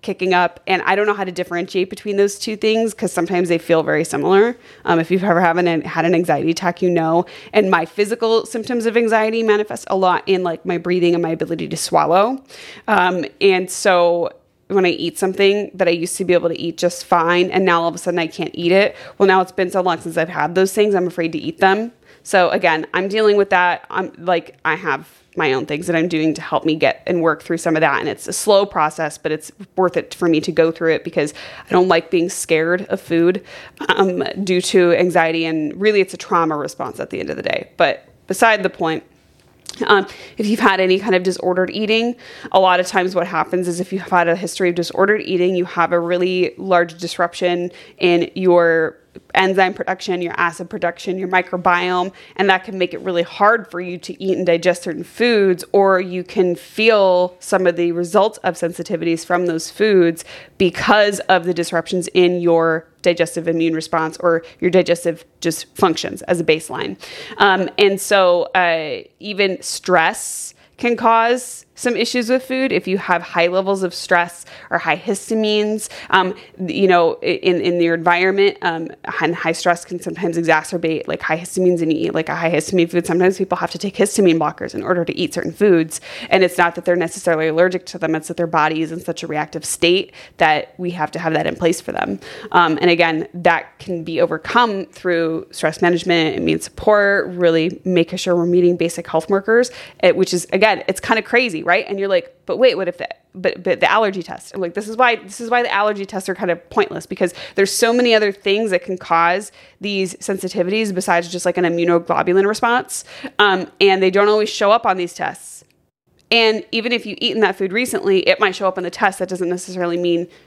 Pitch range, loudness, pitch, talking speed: 170-195 Hz, -17 LUFS, 180 Hz, 215 wpm